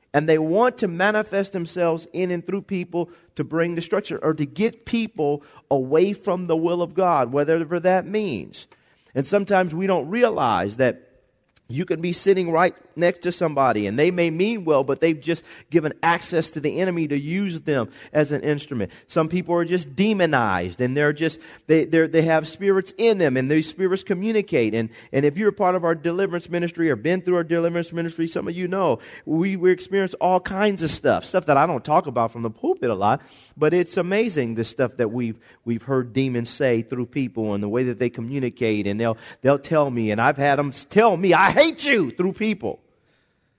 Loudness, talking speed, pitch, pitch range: -22 LUFS, 210 wpm, 165 Hz, 140-185 Hz